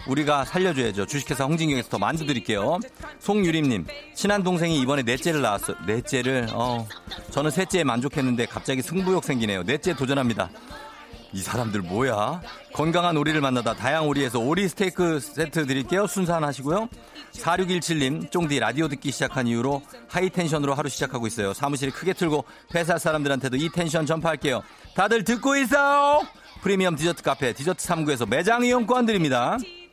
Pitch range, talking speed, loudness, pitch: 130-180 Hz, 390 characters per minute, -24 LUFS, 150 Hz